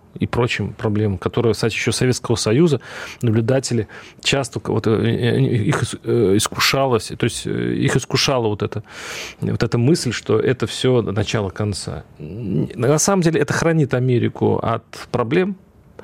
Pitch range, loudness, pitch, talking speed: 110-130 Hz, -19 LUFS, 120 Hz, 130 wpm